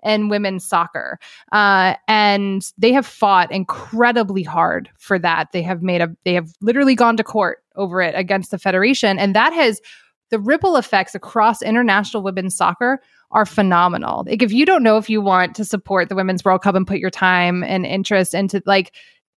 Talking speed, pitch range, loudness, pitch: 190 wpm, 185-220 Hz, -17 LUFS, 200 Hz